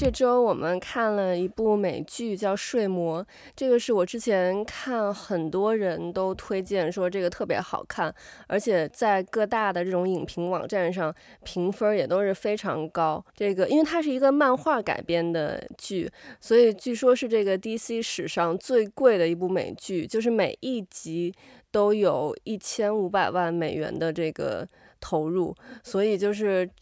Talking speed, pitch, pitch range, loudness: 245 characters per minute, 200 Hz, 180-225 Hz, -26 LUFS